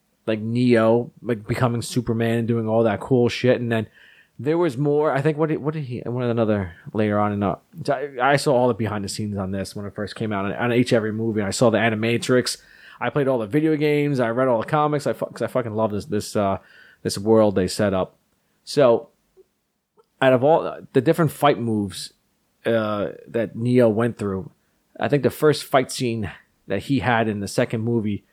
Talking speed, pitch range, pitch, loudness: 215 wpm, 105-130 Hz, 115 Hz, -22 LUFS